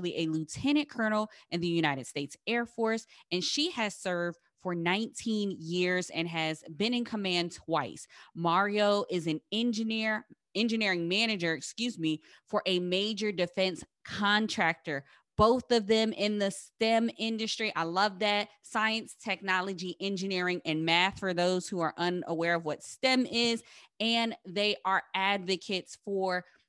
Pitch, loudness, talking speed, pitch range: 195 Hz, -30 LUFS, 145 wpm, 175-220 Hz